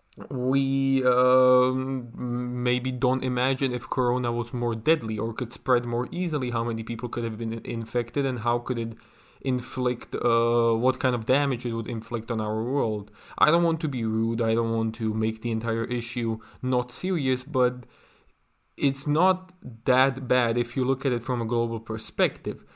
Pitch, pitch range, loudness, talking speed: 125 Hz, 115-130 Hz, -26 LUFS, 180 wpm